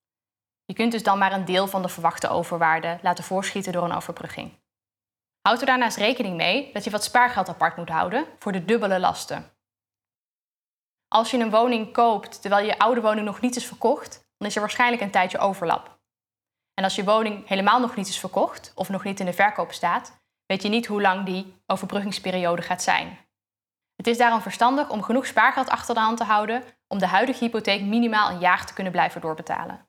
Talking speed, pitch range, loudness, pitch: 200 wpm, 180-225 Hz, -23 LUFS, 200 Hz